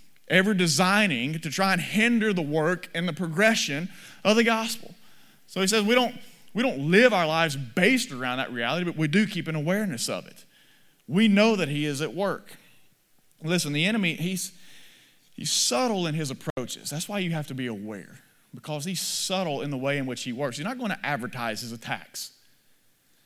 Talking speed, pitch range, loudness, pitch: 195 wpm, 145-210 Hz, -25 LUFS, 175 Hz